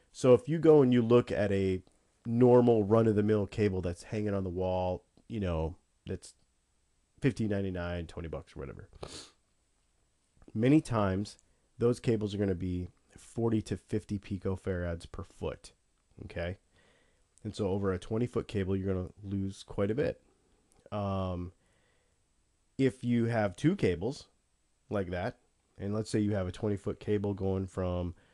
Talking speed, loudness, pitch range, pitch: 160 wpm, -31 LUFS, 90-110 Hz, 100 Hz